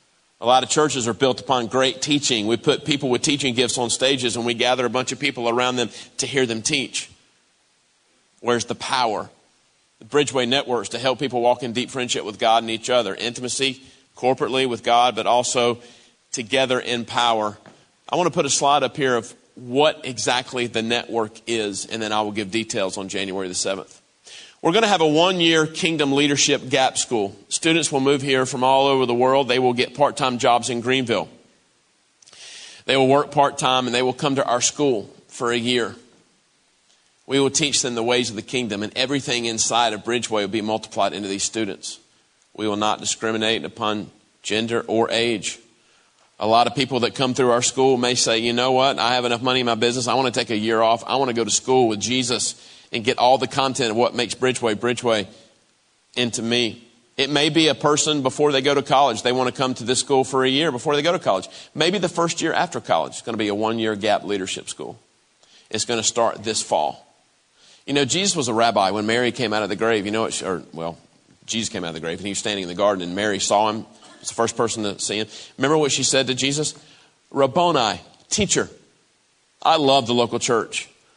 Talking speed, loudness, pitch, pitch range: 225 wpm, -20 LUFS, 120 Hz, 115-135 Hz